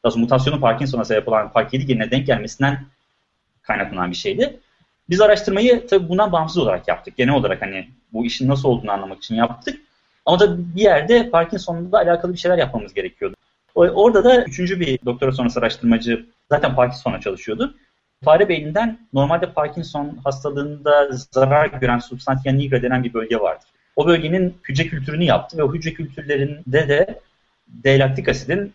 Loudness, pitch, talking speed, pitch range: -18 LUFS, 140 Hz, 150 wpm, 125-175 Hz